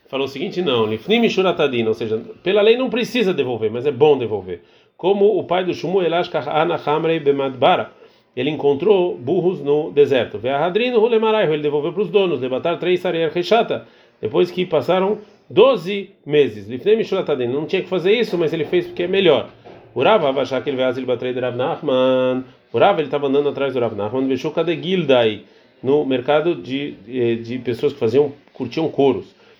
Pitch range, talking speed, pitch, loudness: 130-195 Hz, 160 wpm, 160 Hz, -18 LUFS